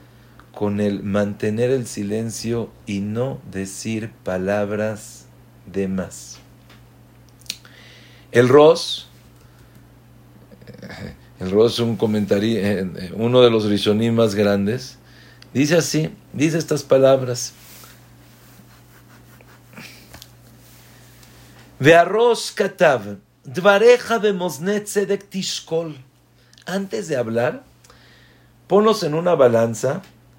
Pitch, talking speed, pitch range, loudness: 120 Hz, 80 wpm, 110-155 Hz, -19 LUFS